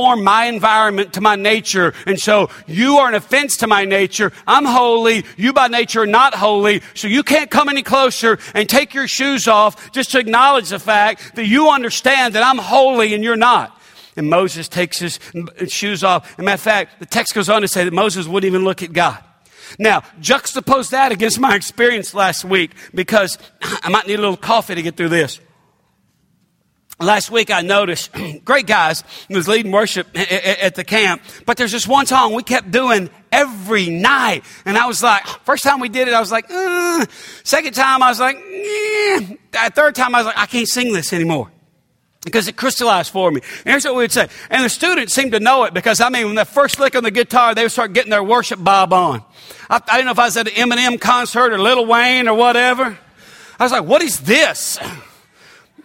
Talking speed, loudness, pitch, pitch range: 210 wpm, -14 LUFS, 225 Hz, 195-255 Hz